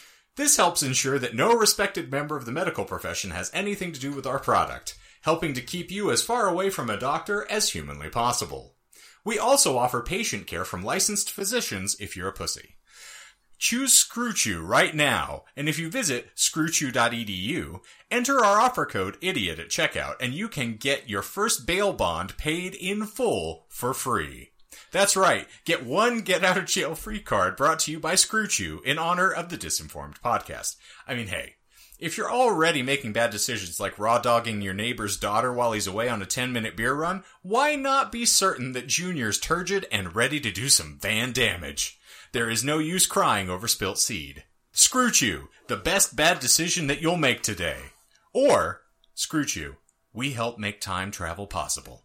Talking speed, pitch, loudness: 180 wpm, 140 Hz, -24 LUFS